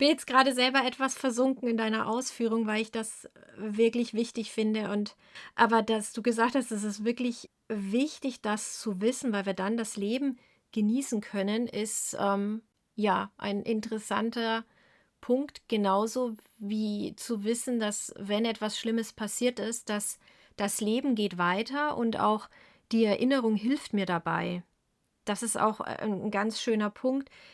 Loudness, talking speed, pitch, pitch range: -30 LUFS, 155 wpm, 225 Hz, 210-240 Hz